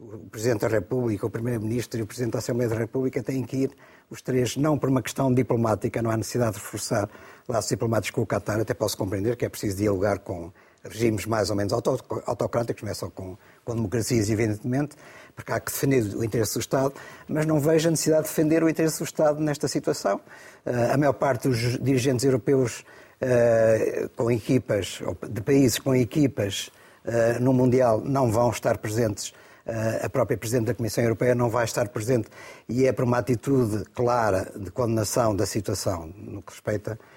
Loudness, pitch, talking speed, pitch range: -25 LUFS, 120 Hz, 190 wpm, 110-130 Hz